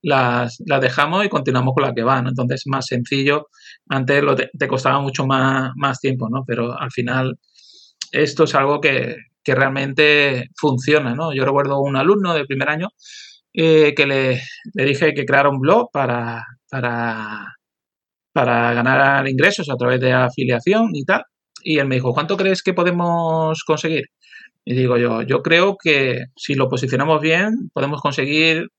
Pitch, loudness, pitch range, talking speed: 140 Hz, -17 LUFS, 130-155 Hz, 165 wpm